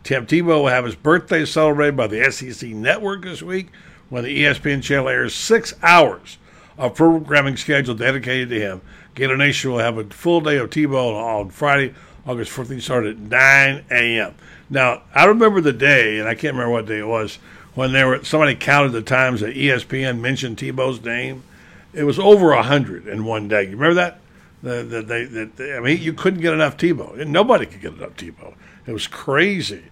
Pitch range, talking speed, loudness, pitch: 120-155 Hz, 195 wpm, -17 LUFS, 135 Hz